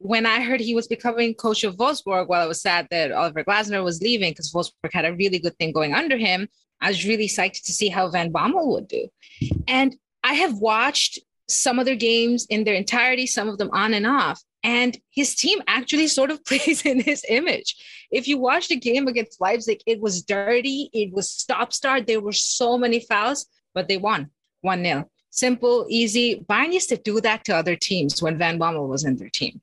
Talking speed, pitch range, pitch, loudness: 215 wpm, 190-260 Hz, 225 Hz, -21 LUFS